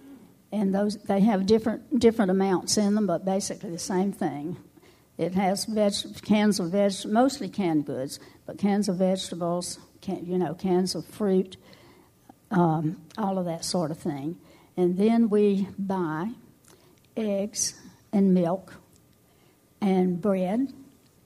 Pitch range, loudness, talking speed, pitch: 175-210 Hz, -26 LUFS, 140 wpm, 190 Hz